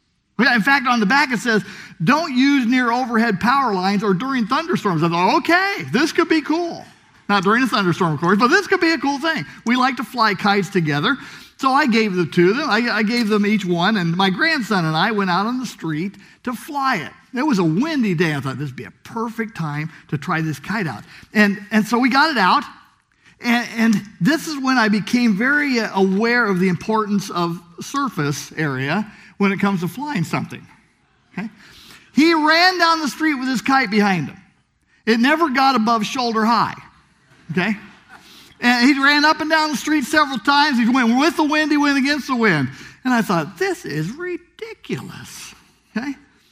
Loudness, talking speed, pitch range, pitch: -18 LUFS, 205 wpm, 195-280 Hz, 230 Hz